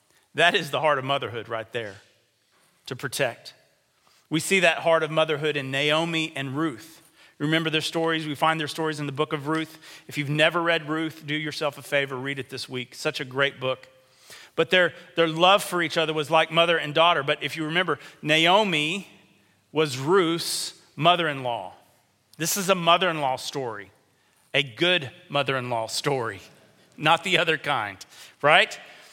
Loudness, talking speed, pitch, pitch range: -24 LUFS, 185 wpm, 155 Hz, 140-165 Hz